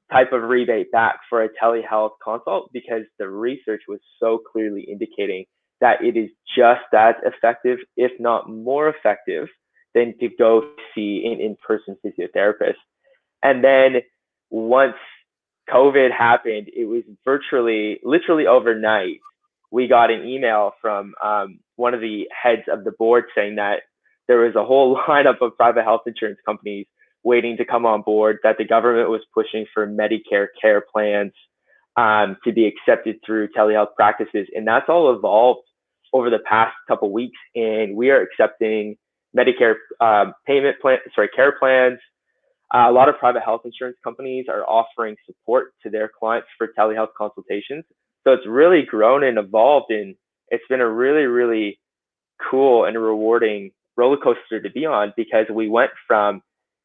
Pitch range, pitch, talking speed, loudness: 110-135 Hz, 115 Hz, 160 wpm, -18 LUFS